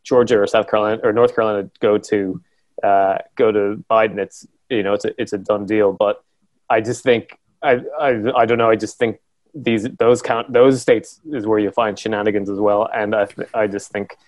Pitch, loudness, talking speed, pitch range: 105 Hz, -18 LUFS, 220 wpm, 105-110 Hz